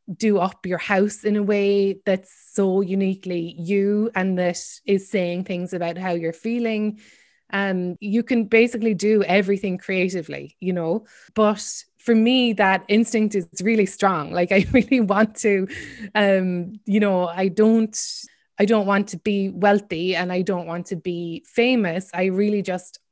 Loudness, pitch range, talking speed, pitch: -21 LUFS, 185-215 Hz, 165 wpm, 195 Hz